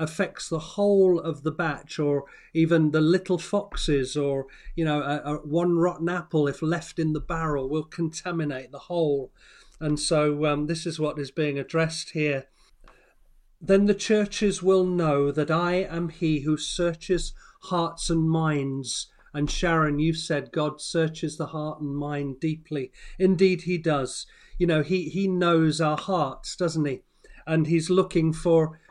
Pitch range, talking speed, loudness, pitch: 150-175 Hz, 165 wpm, -25 LUFS, 160 Hz